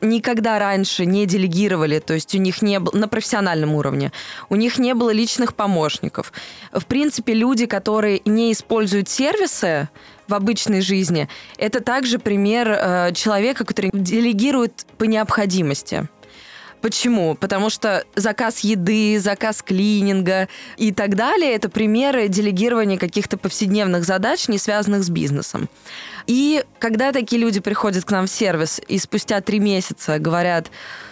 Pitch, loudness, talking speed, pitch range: 210 Hz, -19 LUFS, 140 wpm, 190-225 Hz